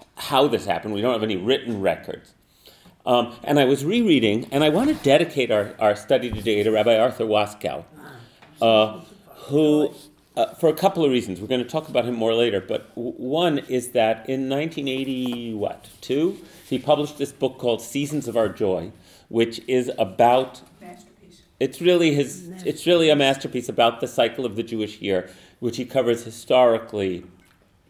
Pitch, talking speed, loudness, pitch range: 125 Hz, 175 wpm, -22 LUFS, 115-145 Hz